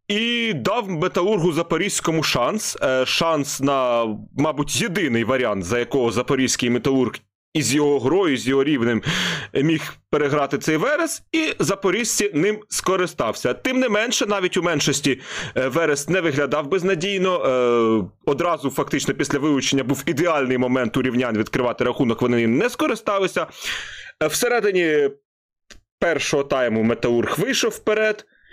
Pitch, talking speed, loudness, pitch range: 150 Hz, 125 wpm, -20 LUFS, 130-195 Hz